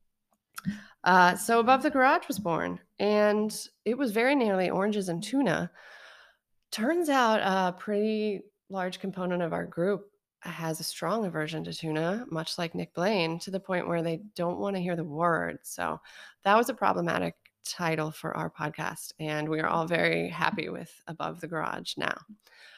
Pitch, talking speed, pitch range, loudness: 190 Hz, 170 wpm, 165-215 Hz, -29 LUFS